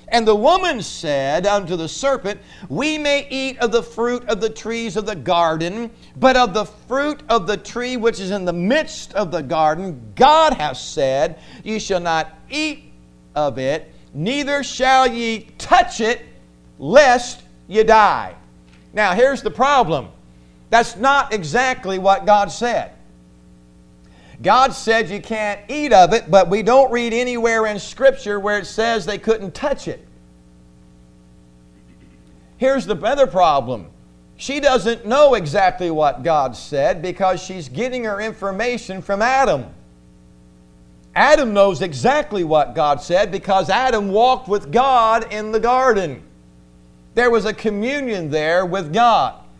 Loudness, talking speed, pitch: -17 LUFS, 145 wpm, 205 Hz